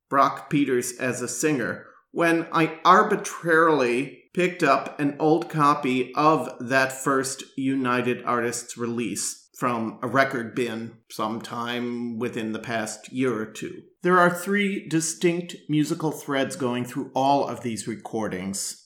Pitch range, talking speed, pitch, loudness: 120-155 Hz, 135 wpm, 130 Hz, -24 LUFS